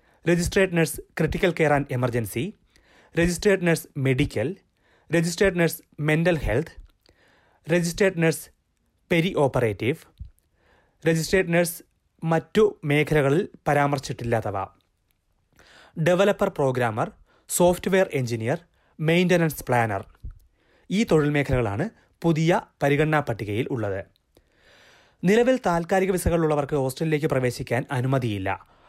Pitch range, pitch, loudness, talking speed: 120-170 Hz, 150 Hz, -24 LUFS, 85 wpm